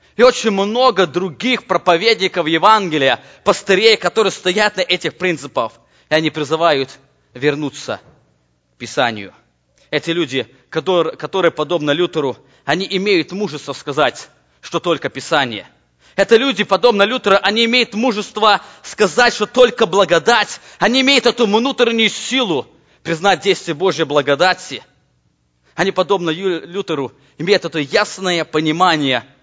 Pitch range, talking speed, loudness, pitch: 150-210 Hz, 115 wpm, -15 LUFS, 180 Hz